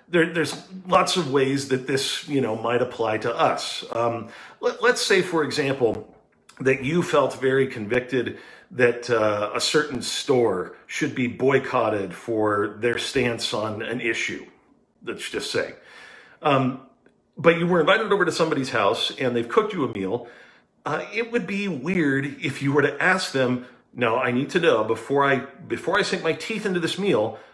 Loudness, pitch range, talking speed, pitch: -23 LUFS, 120-165 Hz, 180 wpm, 135 Hz